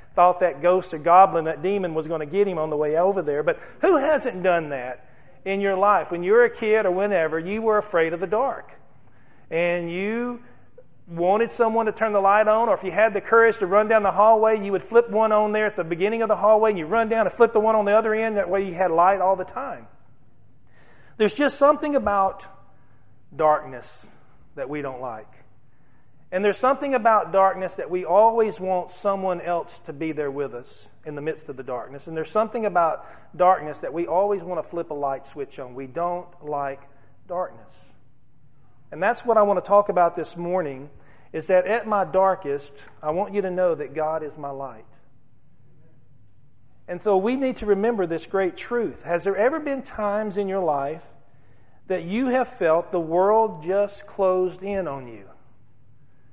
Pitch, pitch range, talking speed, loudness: 180 Hz, 140-210 Hz, 205 wpm, -22 LUFS